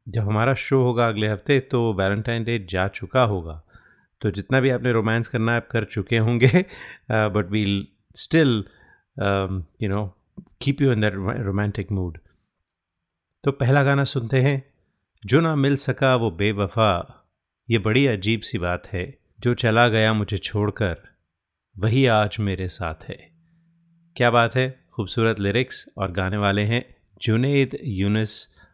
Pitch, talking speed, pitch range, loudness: 110 Hz, 150 wpm, 100-130 Hz, -22 LUFS